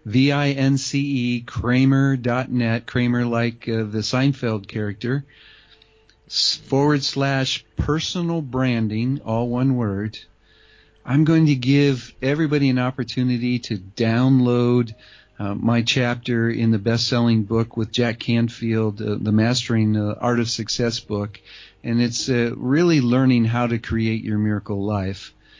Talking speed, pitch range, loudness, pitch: 140 wpm, 110-130 Hz, -21 LUFS, 120 Hz